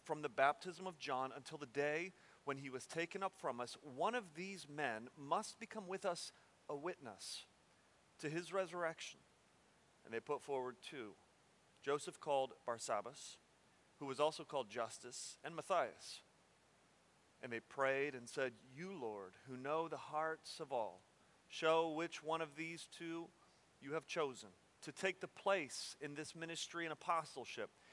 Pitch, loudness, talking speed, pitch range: 160 Hz, -44 LUFS, 160 wpm, 135-170 Hz